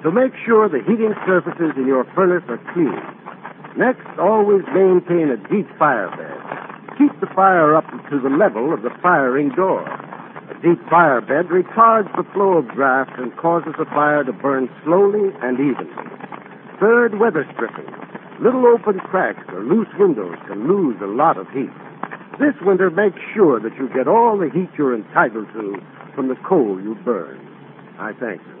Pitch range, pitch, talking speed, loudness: 150-215 Hz, 180 Hz, 175 wpm, -17 LUFS